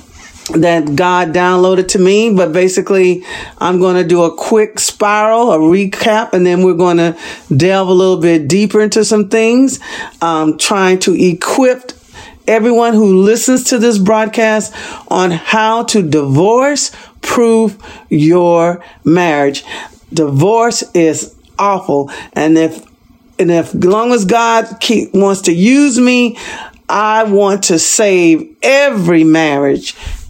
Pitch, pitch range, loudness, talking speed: 195 Hz, 170-225 Hz, -11 LUFS, 135 wpm